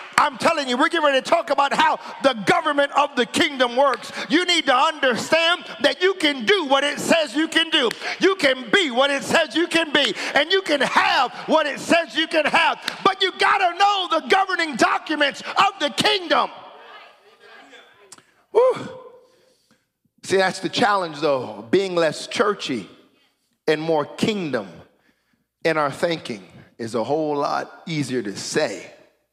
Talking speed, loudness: 165 wpm, -20 LUFS